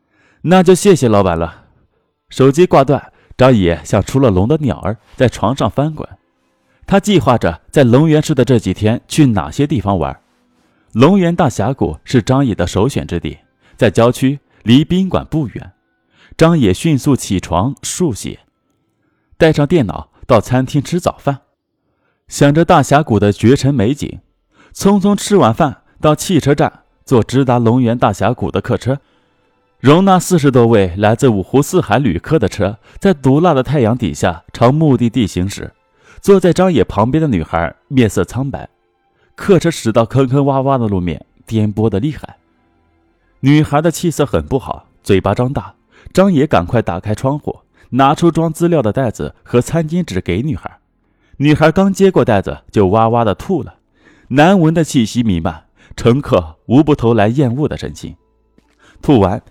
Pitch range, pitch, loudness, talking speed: 100-150 Hz, 125 Hz, -13 LUFS, 240 characters per minute